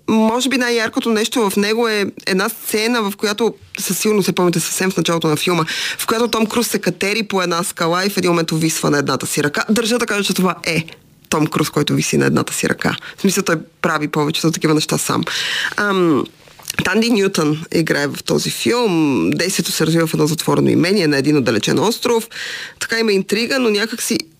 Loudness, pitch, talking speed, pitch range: -17 LUFS, 185 Hz, 210 wpm, 160-220 Hz